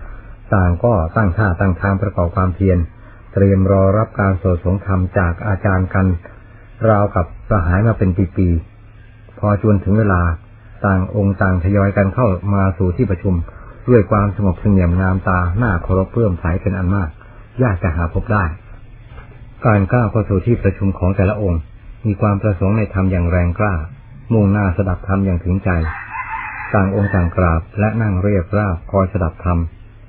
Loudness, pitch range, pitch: -17 LUFS, 95-105 Hz, 100 Hz